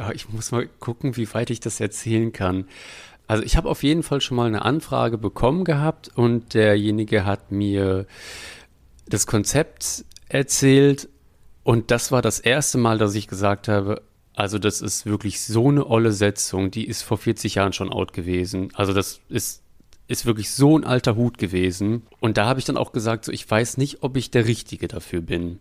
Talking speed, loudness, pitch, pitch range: 190 wpm, -22 LUFS, 110 Hz, 100-120 Hz